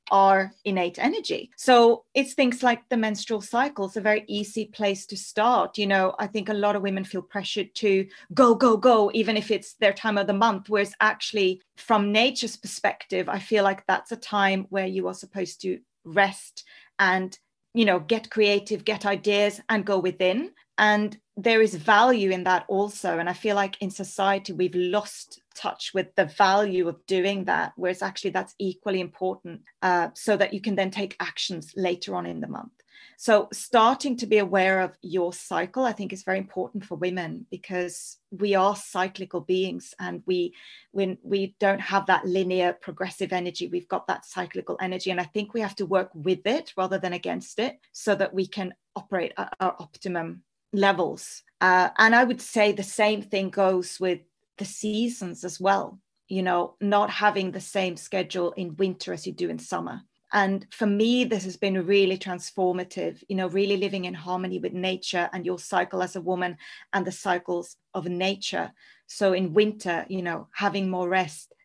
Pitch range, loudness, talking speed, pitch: 185-210 Hz, -25 LUFS, 190 wpm, 195 Hz